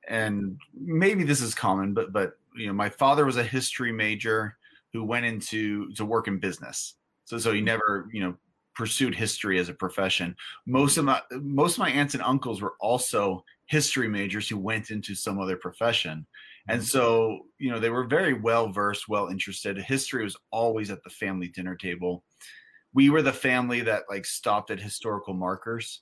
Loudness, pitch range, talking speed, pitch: -27 LUFS, 100-125 Hz, 185 wpm, 110 Hz